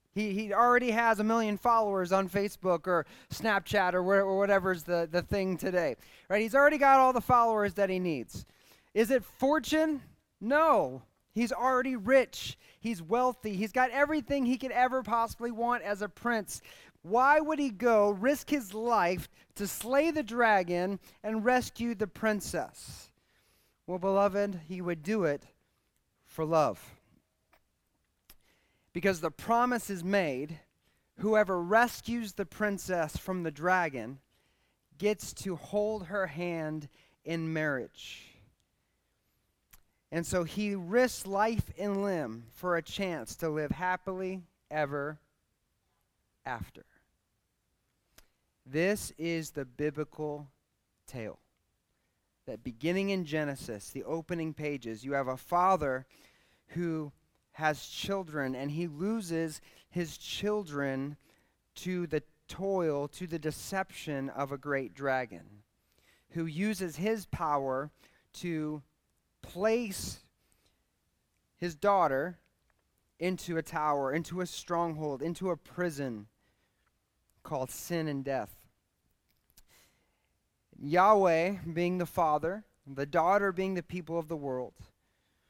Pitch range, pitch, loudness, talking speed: 150-210 Hz, 180 Hz, -31 LUFS, 120 wpm